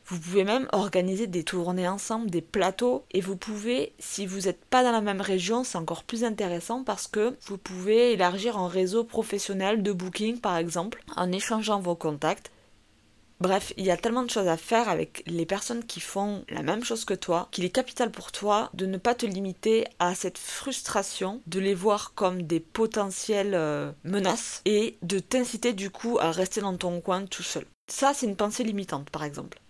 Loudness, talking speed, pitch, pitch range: -28 LUFS, 200 wpm, 195 Hz, 180-225 Hz